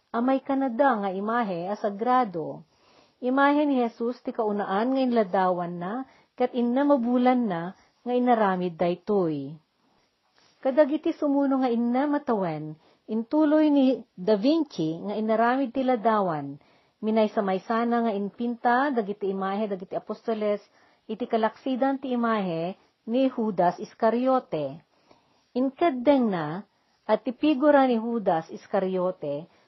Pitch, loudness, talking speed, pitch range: 230 Hz, -25 LUFS, 115 wpm, 195-260 Hz